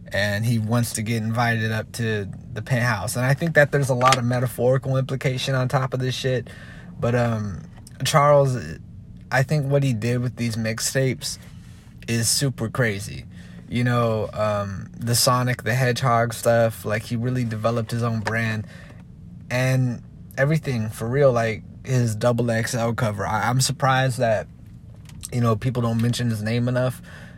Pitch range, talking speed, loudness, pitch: 110-130 Hz, 165 wpm, -22 LUFS, 120 Hz